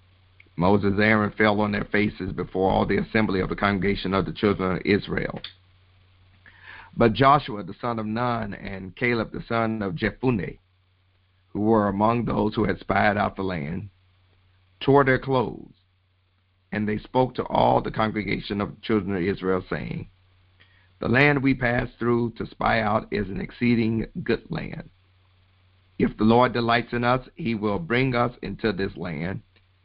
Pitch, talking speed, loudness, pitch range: 100 Hz, 165 wpm, -24 LUFS, 95-115 Hz